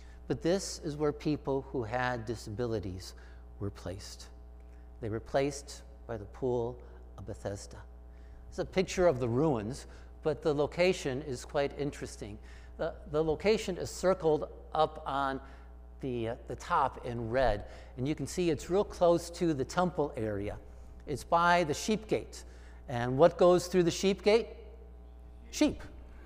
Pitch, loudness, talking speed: 125 Hz, -32 LUFS, 155 wpm